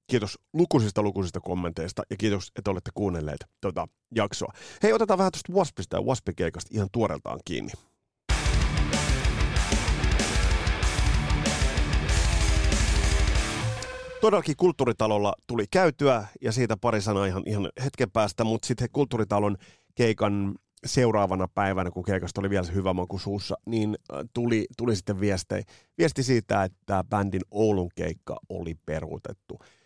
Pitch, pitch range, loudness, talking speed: 105 Hz, 95-115 Hz, -27 LUFS, 120 wpm